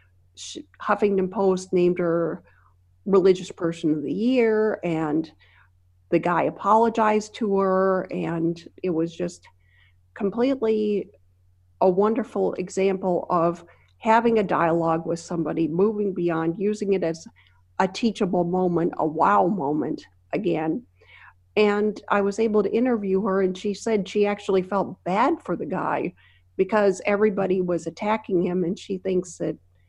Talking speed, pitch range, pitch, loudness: 135 wpm, 160-205 Hz, 185 Hz, -23 LUFS